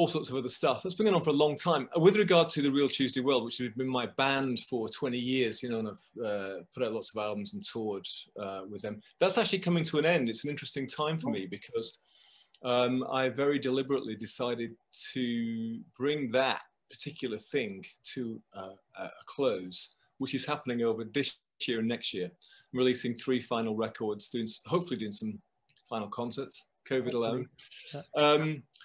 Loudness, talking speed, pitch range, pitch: -31 LUFS, 195 wpm, 115-150 Hz, 130 Hz